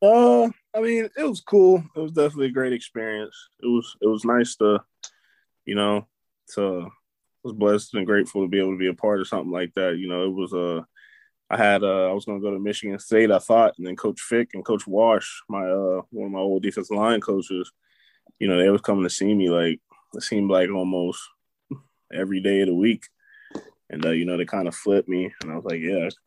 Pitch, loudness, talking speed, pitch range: 100 Hz, -23 LUFS, 235 wpm, 95-115 Hz